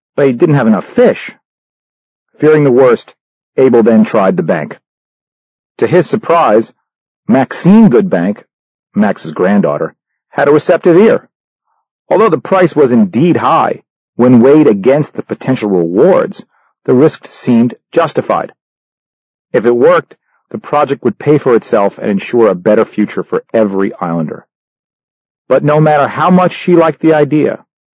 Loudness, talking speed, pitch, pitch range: -10 LUFS, 140 wpm, 145 Hz, 120-170 Hz